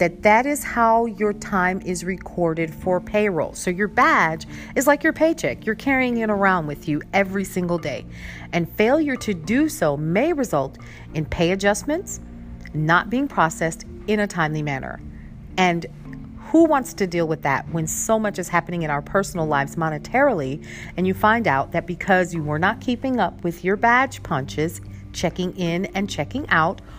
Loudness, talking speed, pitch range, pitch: -21 LUFS, 180 wpm, 155-215 Hz, 180 Hz